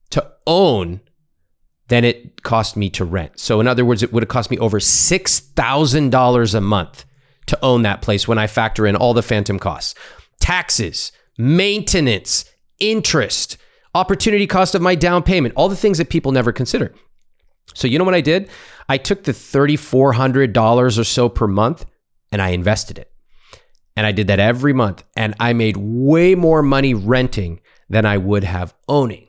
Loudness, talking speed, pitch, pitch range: -16 LUFS, 170 wpm, 120 Hz, 105-150 Hz